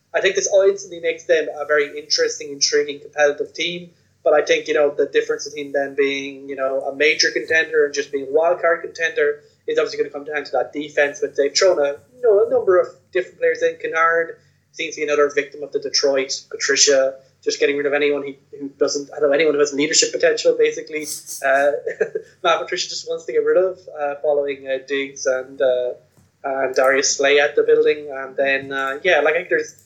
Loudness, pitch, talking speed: -19 LUFS, 165 Hz, 220 wpm